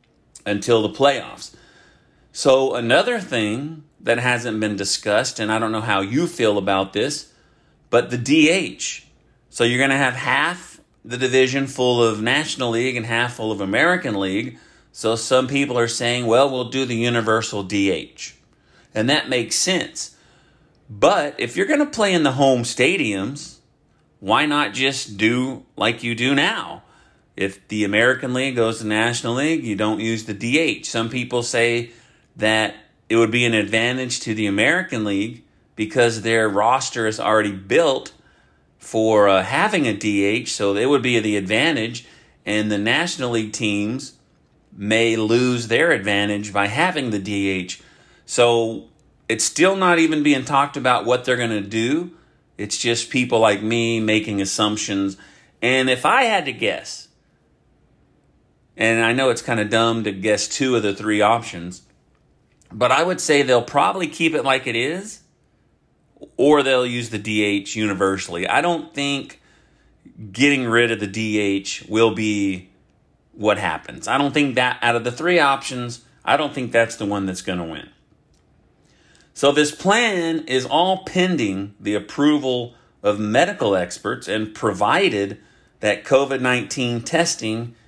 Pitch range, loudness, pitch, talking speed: 105-135 Hz, -19 LUFS, 115 Hz, 160 wpm